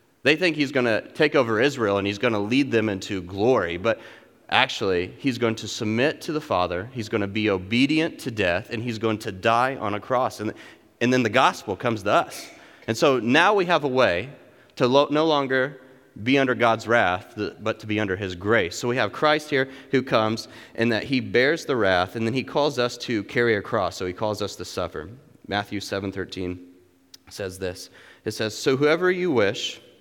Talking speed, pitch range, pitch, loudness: 215 wpm, 100-130 Hz, 115 Hz, -23 LUFS